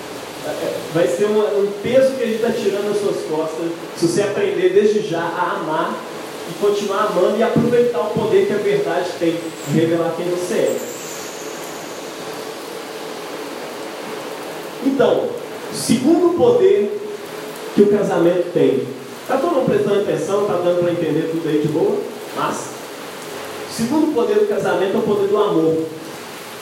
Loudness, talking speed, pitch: -19 LUFS, 150 wpm, 210 Hz